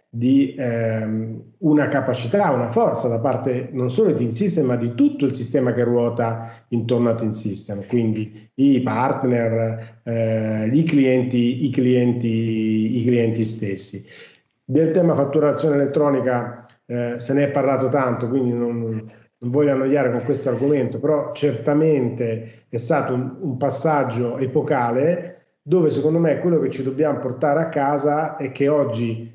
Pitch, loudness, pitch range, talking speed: 125 Hz, -20 LUFS, 115-145 Hz, 145 wpm